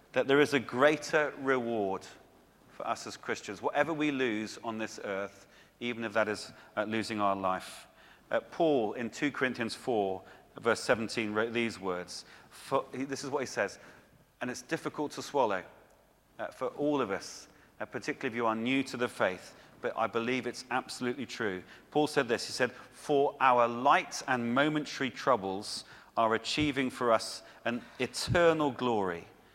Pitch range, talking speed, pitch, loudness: 110-140 Hz, 175 wpm, 120 Hz, -32 LUFS